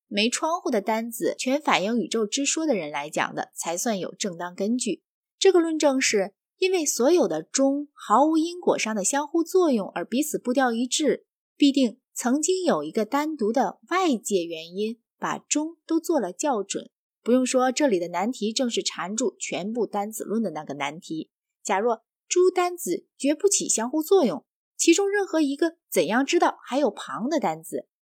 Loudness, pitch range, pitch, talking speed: -24 LUFS, 215-320 Hz, 265 Hz, 265 characters per minute